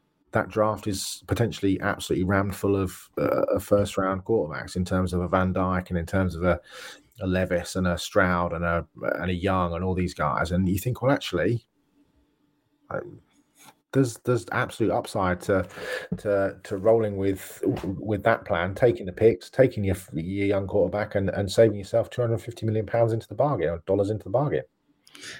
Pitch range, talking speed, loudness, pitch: 90-110 Hz, 190 wpm, -26 LUFS, 95 Hz